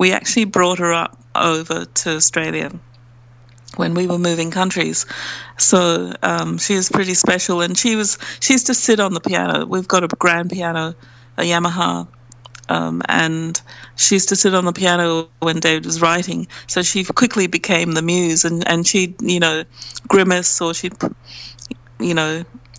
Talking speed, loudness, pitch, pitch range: 170 wpm, -16 LUFS, 170 Hz, 125-185 Hz